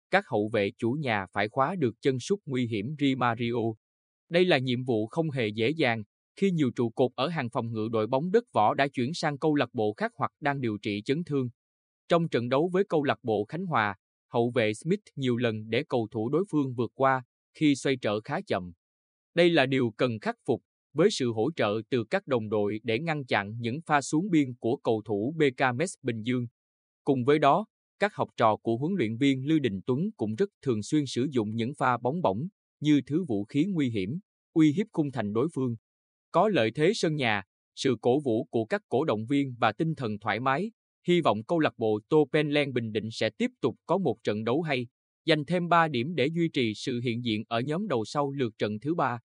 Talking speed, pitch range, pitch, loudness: 230 wpm, 110-150 Hz, 125 Hz, -28 LUFS